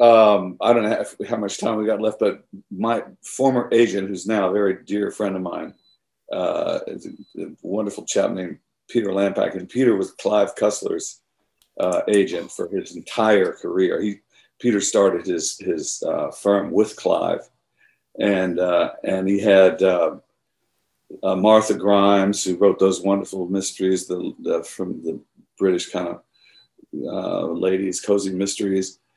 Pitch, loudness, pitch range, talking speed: 100 Hz, -21 LUFS, 95-110 Hz, 155 wpm